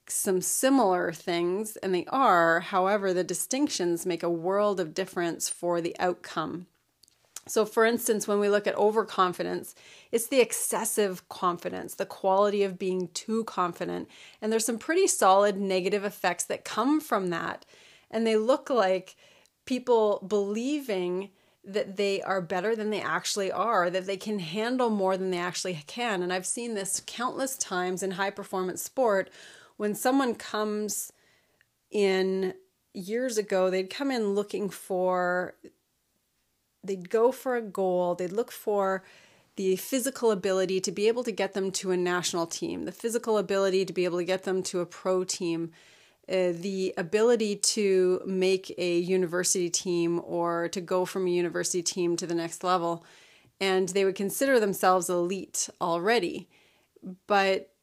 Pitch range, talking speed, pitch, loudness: 180-215 Hz, 155 wpm, 190 Hz, -28 LUFS